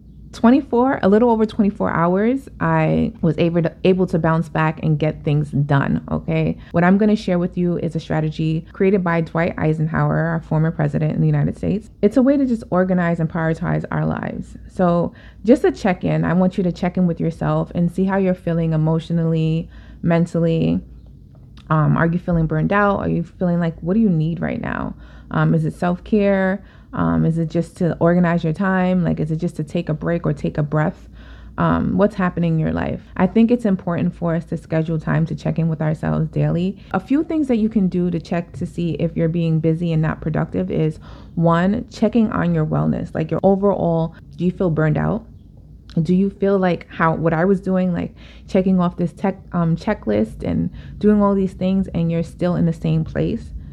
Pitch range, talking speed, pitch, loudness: 155-190 Hz, 215 wpm, 170 Hz, -19 LUFS